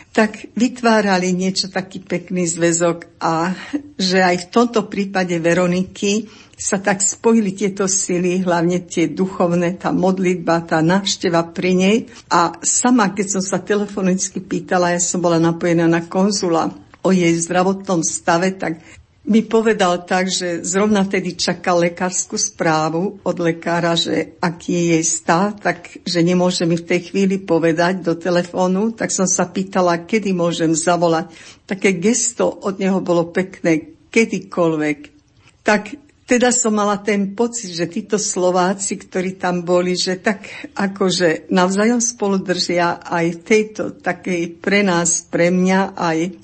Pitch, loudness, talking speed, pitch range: 185 Hz, -17 LUFS, 145 wpm, 170-200 Hz